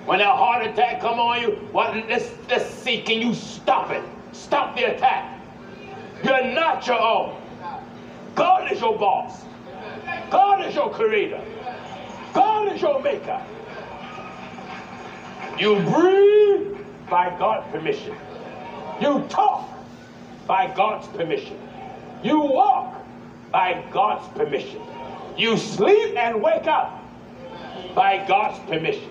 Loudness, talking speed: -21 LUFS, 115 wpm